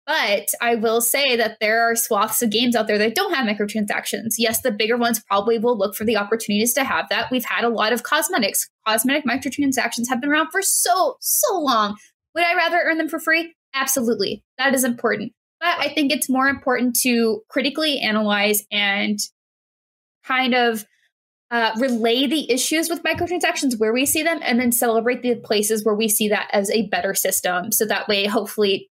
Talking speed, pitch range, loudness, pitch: 195 wpm, 220-275 Hz, -19 LUFS, 235 Hz